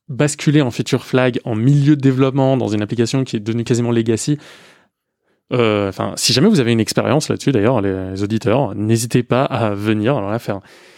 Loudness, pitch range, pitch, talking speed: -17 LUFS, 110-135 Hz, 120 Hz, 190 wpm